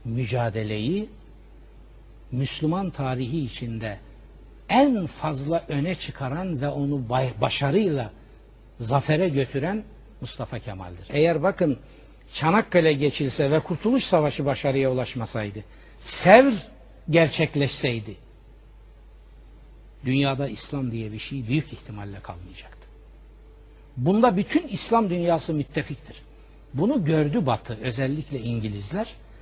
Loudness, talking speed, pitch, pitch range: -24 LUFS, 90 wpm, 140 Hz, 115-160 Hz